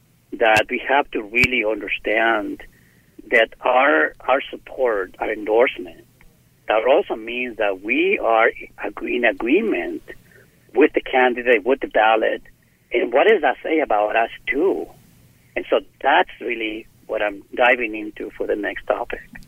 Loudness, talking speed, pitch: -19 LUFS, 140 wpm, 340 Hz